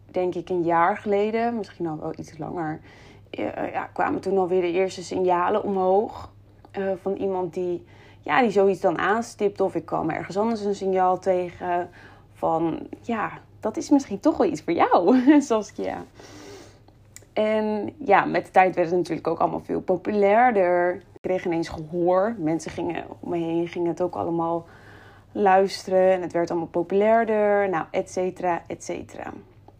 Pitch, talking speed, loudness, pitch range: 185 Hz, 165 wpm, -24 LUFS, 170-195 Hz